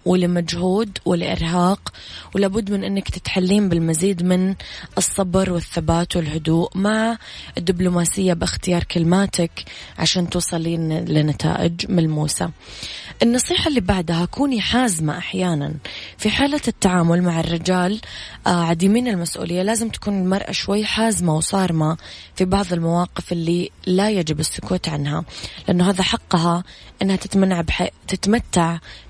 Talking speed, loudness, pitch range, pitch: 110 wpm, -20 LUFS, 170-195 Hz, 180 Hz